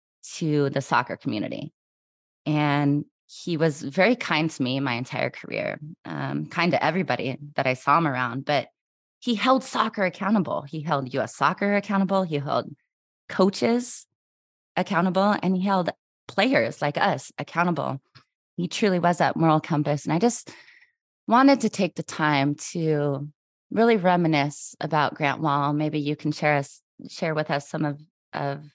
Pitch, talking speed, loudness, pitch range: 155 Hz, 155 wpm, -24 LUFS, 145-190 Hz